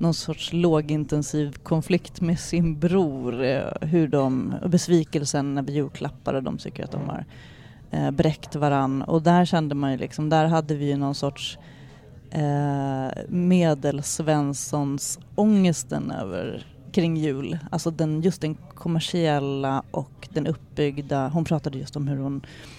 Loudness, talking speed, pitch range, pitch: -25 LUFS, 135 wpm, 140-165 Hz, 150 Hz